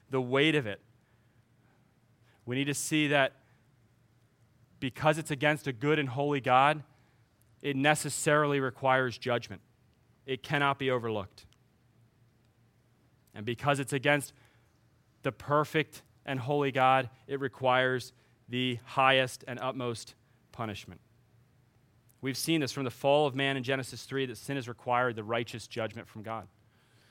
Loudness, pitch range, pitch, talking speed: -30 LUFS, 115-140 Hz, 125 Hz, 135 wpm